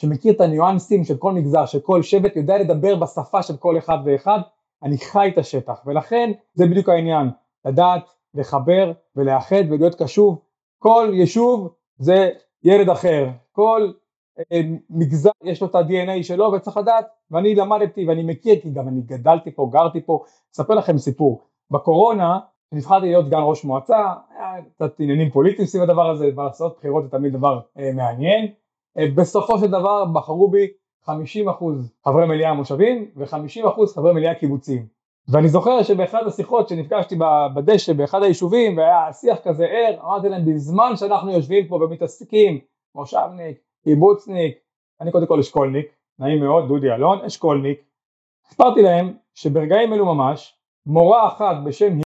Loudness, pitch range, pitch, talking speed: -18 LUFS, 150-200 Hz, 170 Hz, 145 wpm